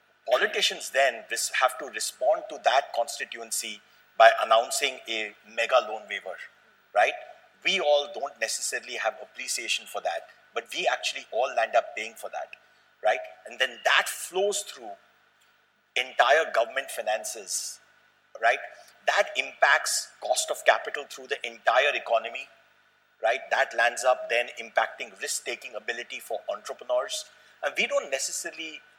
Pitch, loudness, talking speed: 205 Hz, -27 LUFS, 135 wpm